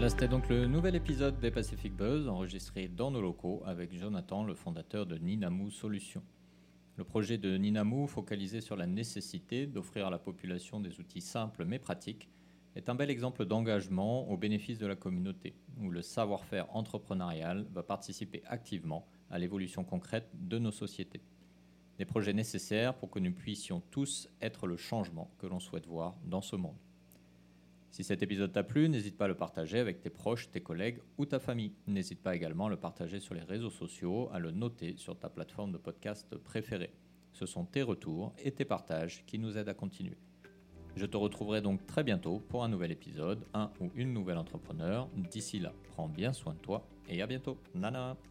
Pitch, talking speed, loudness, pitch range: 100 Hz, 190 wpm, -38 LUFS, 90-115 Hz